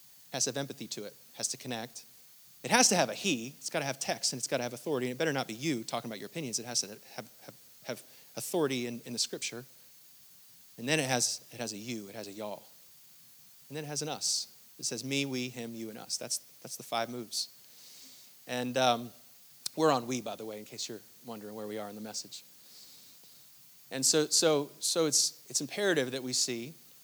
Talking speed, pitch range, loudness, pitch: 235 wpm, 115-140 Hz, -32 LUFS, 125 Hz